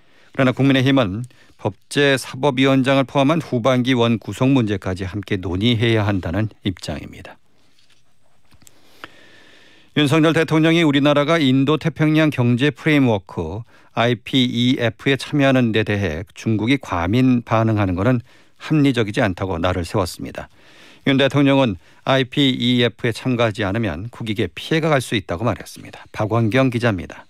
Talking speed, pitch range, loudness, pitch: 320 characters per minute, 105-135 Hz, -18 LUFS, 120 Hz